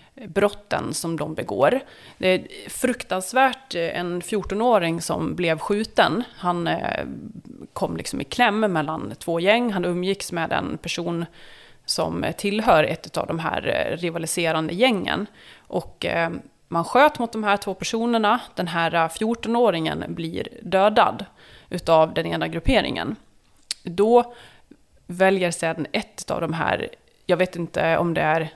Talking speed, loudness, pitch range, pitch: 130 wpm, -23 LUFS, 170-220 Hz, 180 Hz